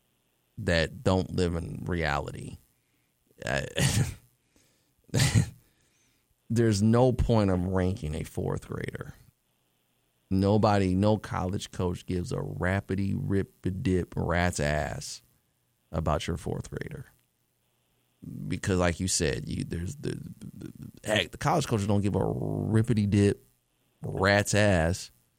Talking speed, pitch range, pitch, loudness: 120 wpm, 90-110 Hz, 95 Hz, -28 LUFS